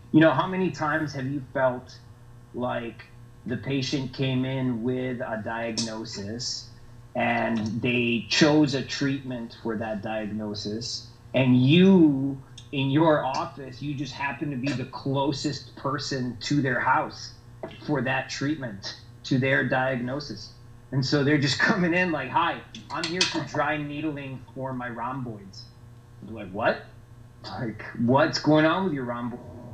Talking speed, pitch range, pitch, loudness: 145 wpm, 120-140 Hz, 125 Hz, -26 LUFS